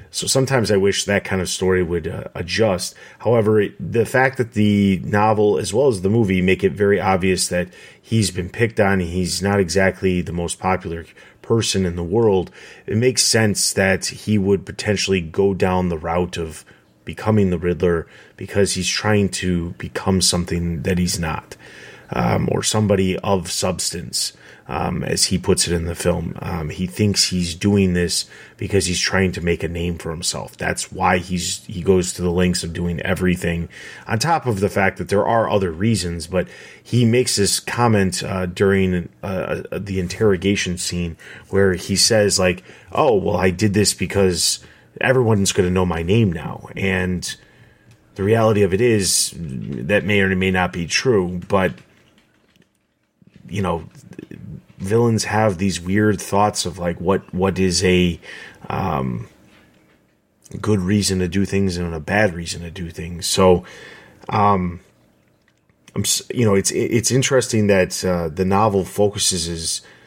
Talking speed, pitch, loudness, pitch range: 170 wpm, 95 Hz, -19 LUFS, 90-105 Hz